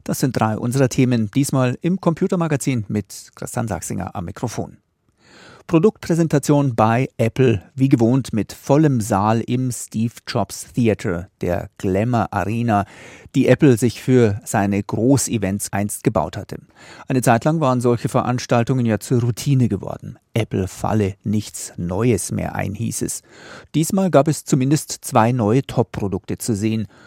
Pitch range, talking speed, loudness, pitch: 105-135 Hz, 135 wpm, -19 LUFS, 120 Hz